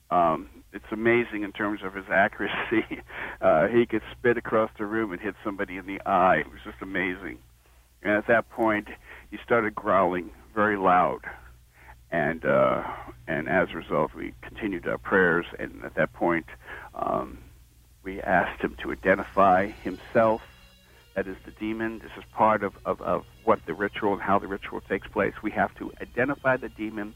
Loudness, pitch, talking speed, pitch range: -26 LUFS, 105 Hz, 175 wpm, 90-110 Hz